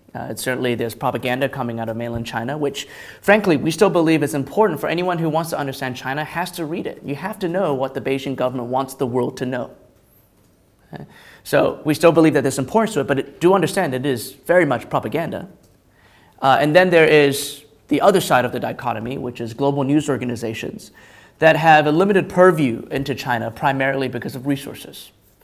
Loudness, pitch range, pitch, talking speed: -19 LUFS, 130-160 Hz, 140 Hz, 210 wpm